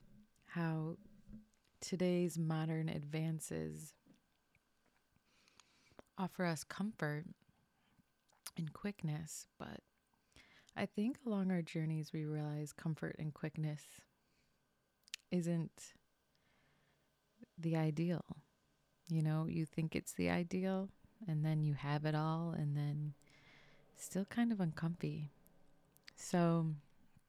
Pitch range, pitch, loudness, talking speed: 150-185 Hz, 160 Hz, -41 LUFS, 95 wpm